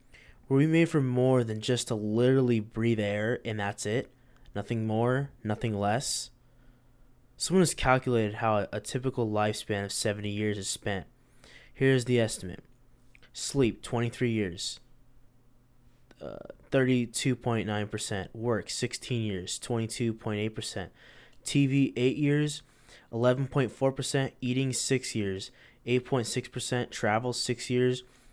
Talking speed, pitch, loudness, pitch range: 110 wpm, 120 Hz, -29 LUFS, 110-125 Hz